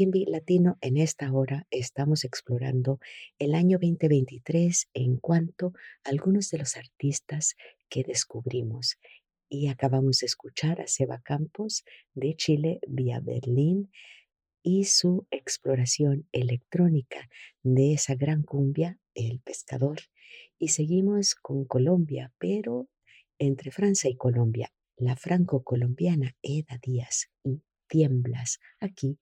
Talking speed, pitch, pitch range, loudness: 115 wpm, 140 Hz, 130-175 Hz, -27 LUFS